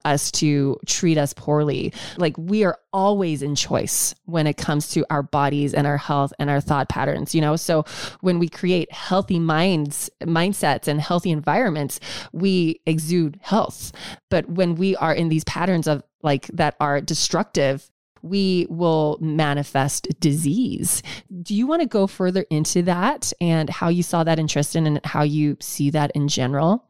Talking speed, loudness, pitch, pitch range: 170 wpm, -21 LUFS, 160 Hz, 145-180 Hz